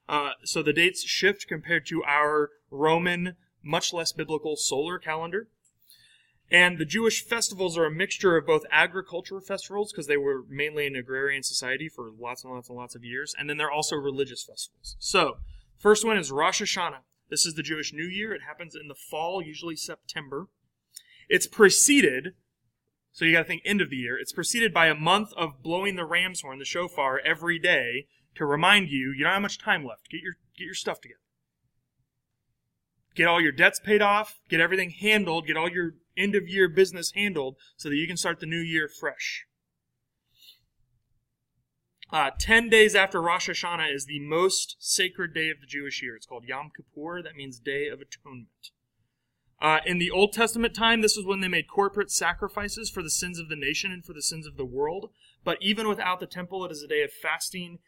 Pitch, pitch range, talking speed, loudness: 165 Hz, 145-190 Hz, 200 wpm, -25 LUFS